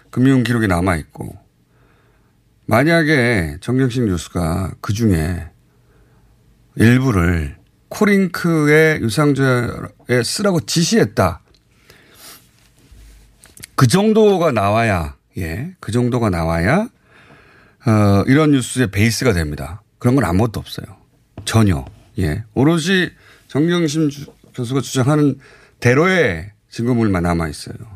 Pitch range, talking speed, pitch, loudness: 95-145 Hz, 225 characters per minute, 120 Hz, -16 LUFS